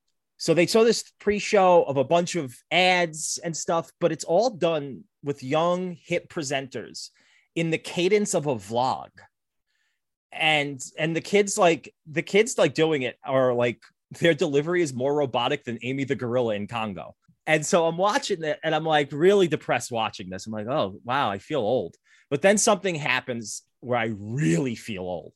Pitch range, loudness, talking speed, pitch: 130-175 Hz, -24 LUFS, 180 wpm, 155 Hz